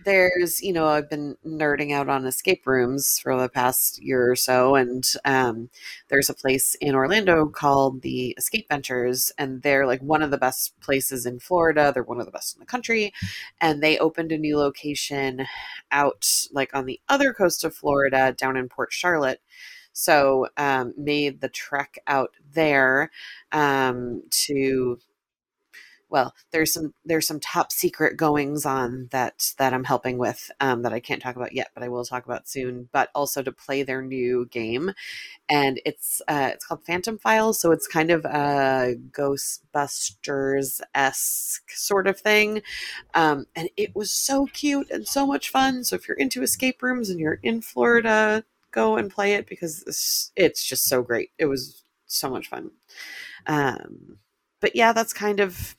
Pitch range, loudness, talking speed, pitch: 130-170 Hz, -23 LUFS, 175 wpm, 140 Hz